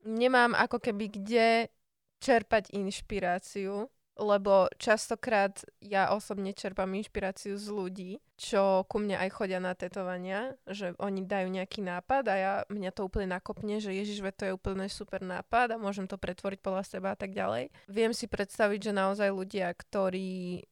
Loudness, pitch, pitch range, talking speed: -32 LUFS, 200 Hz, 190-215 Hz, 160 wpm